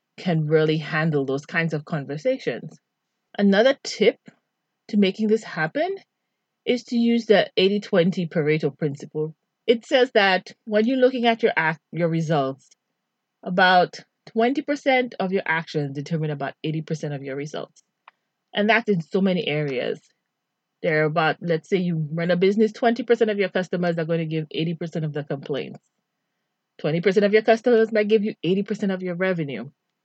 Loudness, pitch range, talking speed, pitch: -22 LUFS, 160-220 Hz, 160 wpm, 185 Hz